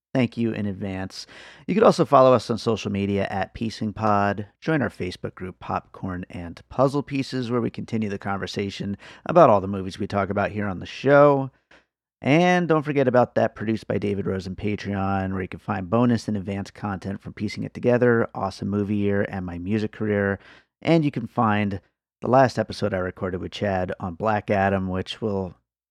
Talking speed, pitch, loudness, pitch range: 190 wpm, 105 Hz, -23 LUFS, 95-115 Hz